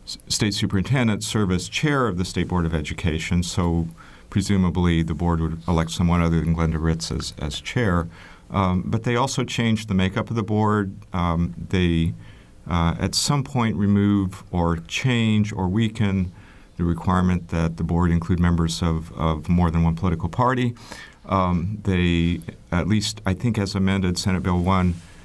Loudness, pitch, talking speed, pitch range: -22 LUFS, 90 Hz, 170 wpm, 85-105 Hz